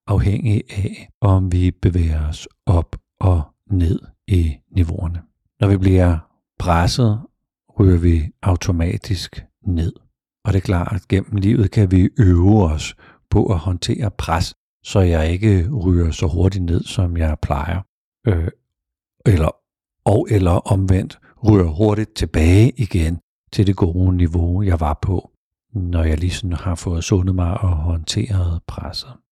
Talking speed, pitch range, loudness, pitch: 140 wpm, 85-100 Hz, -18 LUFS, 95 Hz